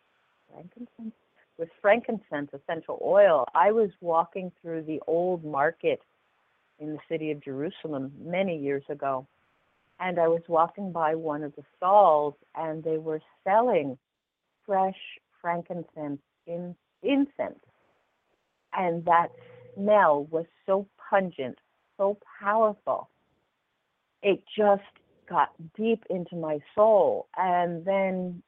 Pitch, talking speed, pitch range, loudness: 170 Hz, 115 wpm, 155-200 Hz, -27 LUFS